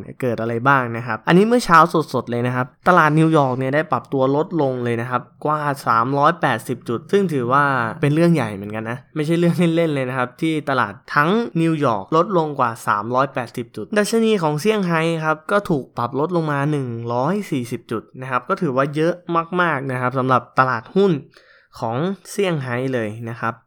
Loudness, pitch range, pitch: -19 LUFS, 125-165 Hz, 140 Hz